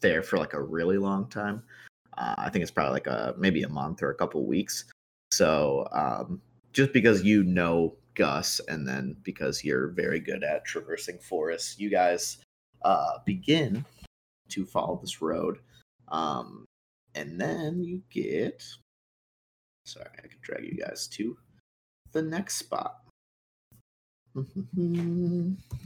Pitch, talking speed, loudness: 105 Hz, 140 wpm, -29 LUFS